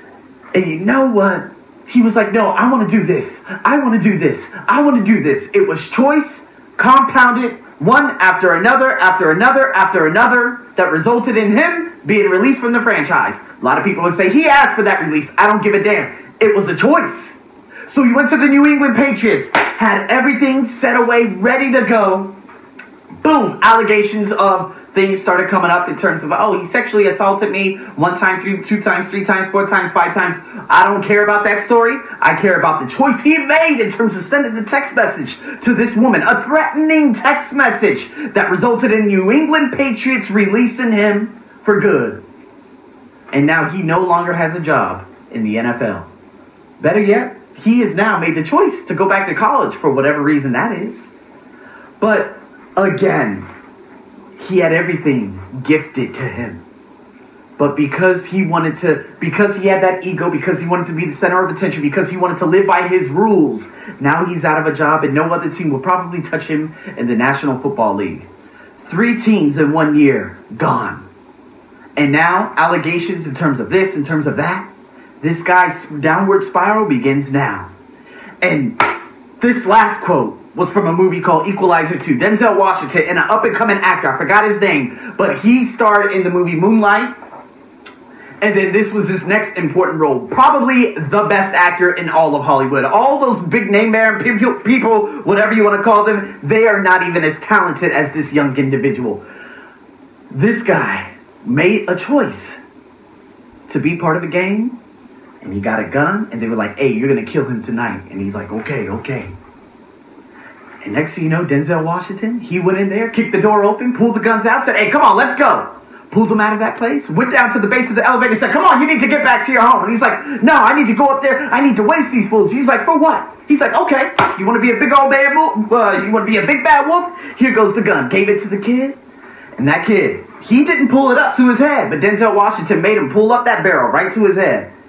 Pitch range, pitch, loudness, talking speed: 180-245 Hz, 205 Hz, -13 LUFS, 210 wpm